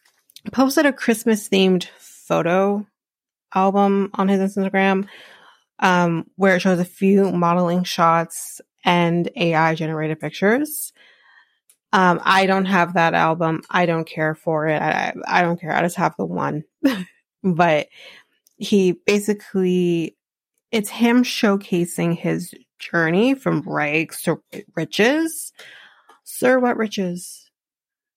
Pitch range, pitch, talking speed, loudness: 170-215 Hz, 190 Hz, 120 wpm, -19 LUFS